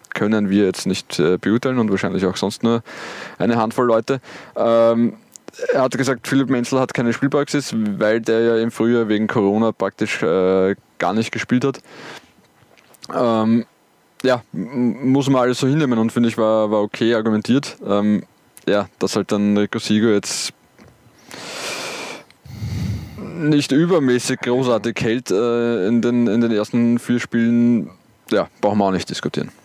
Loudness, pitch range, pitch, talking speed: -19 LUFS, 110-125 Hz, 115 Hz, 155 wpm